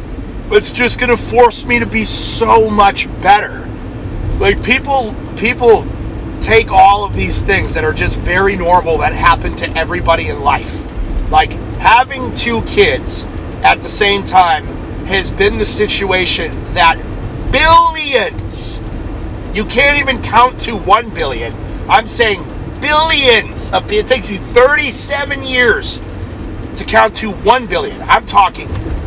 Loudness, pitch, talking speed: -12 LUFS, 260 Hz, 135 wpm